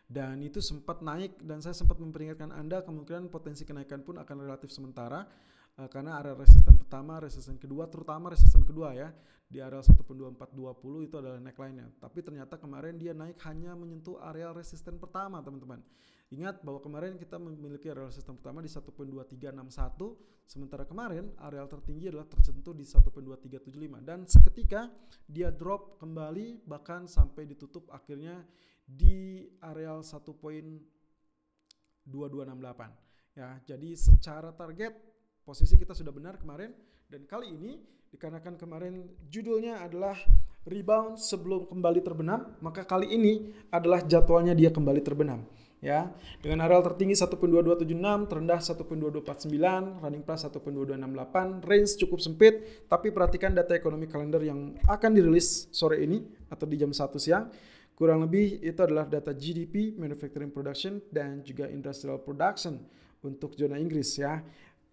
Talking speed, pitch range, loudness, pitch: 135 wpm, 145-180 Hz, -28 LUFS, 160 Hz